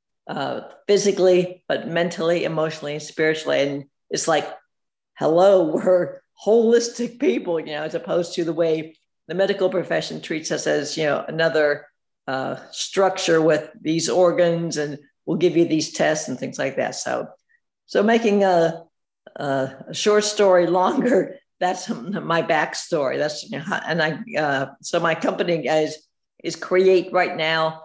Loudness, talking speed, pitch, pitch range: -21 LUFS, 155 wpm, 170 Hz, 155-190 Hz